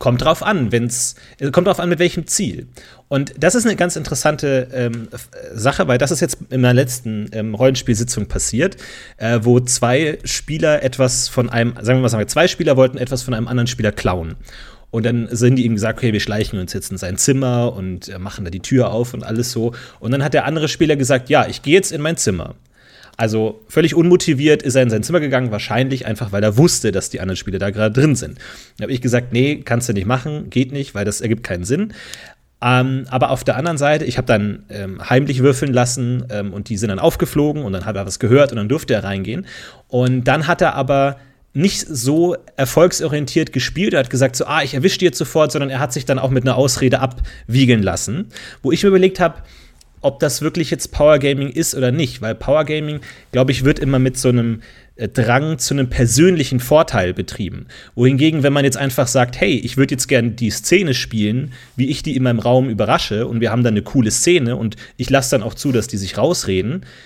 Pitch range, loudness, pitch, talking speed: 115-145 Hz, -17 LUFS, 130 Hz, 220 wpm